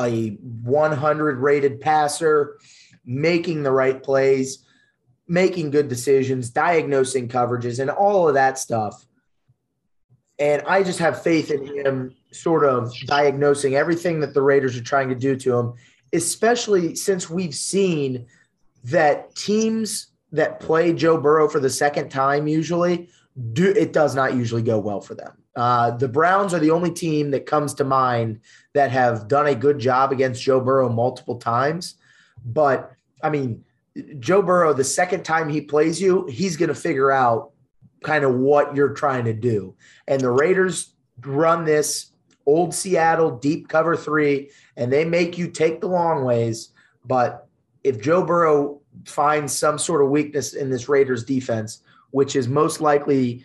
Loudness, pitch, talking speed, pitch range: -20 LUFS, 145 Hz, 160 wpm, 130-165 Hz